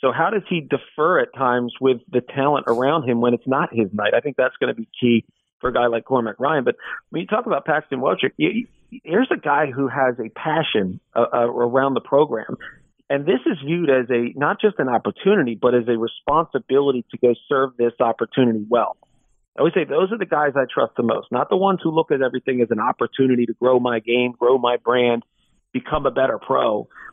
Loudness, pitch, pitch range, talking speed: -20 LUFS, 130 Hz, 120-140 Hz, 225 wpm